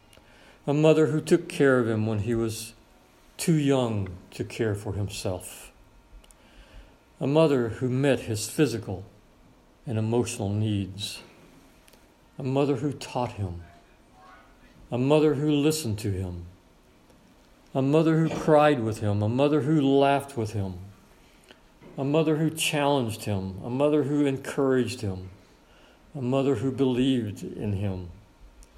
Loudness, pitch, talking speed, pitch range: -26 LUFS, 120 Hz, 135 wpm, 100-140 Hz